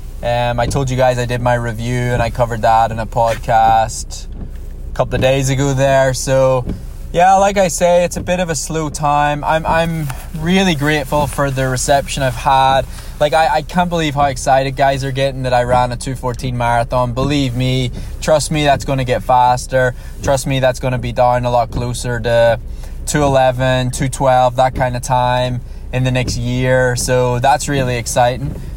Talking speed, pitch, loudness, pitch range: 195 wpm, 130 Hz, -15 LUFS, 120-140 Hz